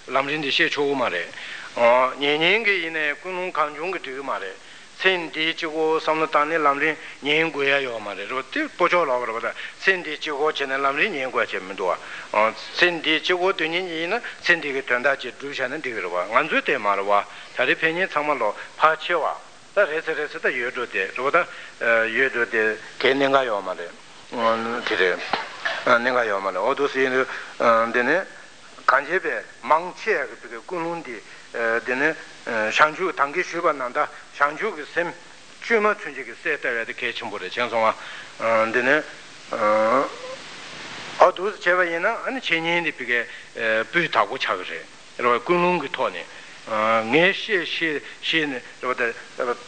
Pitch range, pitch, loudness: 120-165 Hz, 145 Hz, -22 LUFS